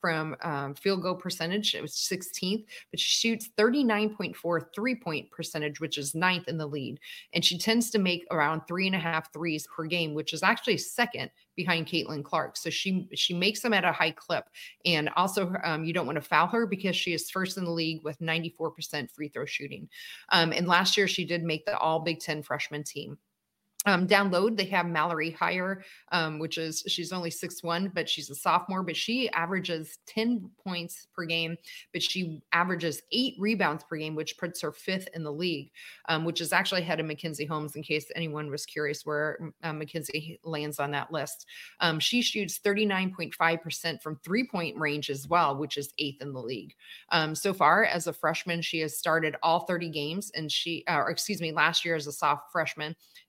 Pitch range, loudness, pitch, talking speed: 155-190 Hz, -29 LUFS, 170 Hz, 205 wpm